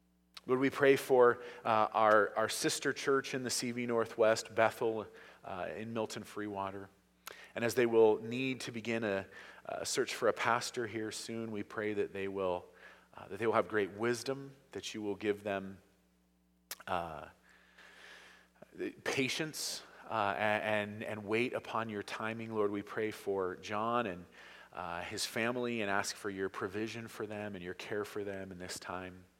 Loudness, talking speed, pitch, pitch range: -35 LUFS, 170 wpm, 110 Hz, 100-120 Hz